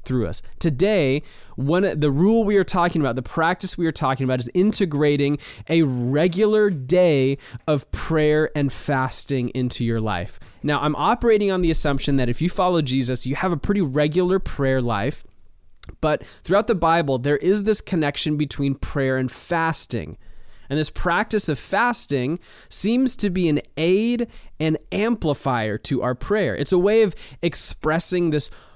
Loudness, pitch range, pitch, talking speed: -21 LUFS, 130-180 Hz, 150 Hz, 165 wpm